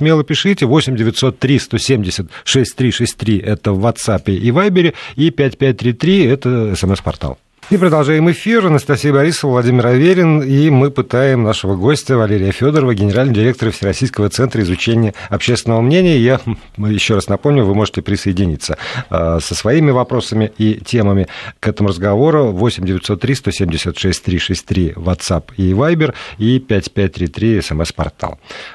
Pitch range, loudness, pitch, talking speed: 100-135 Hz, -14 LUFS, 115 Hz, 135 wpm